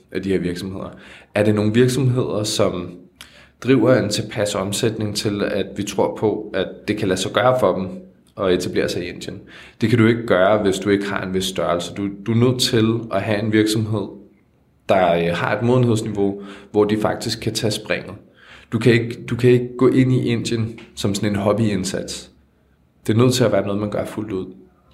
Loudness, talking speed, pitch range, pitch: -19 LUFS, 205 wpm, 95-115 Hz, 105 Hz